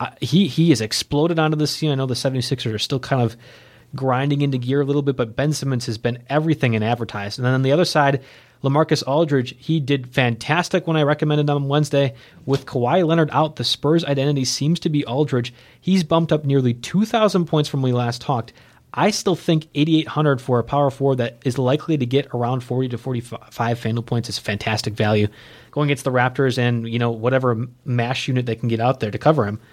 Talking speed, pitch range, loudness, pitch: 225 wpm, 120-150 Hz, -20 LUFS, 135 Hz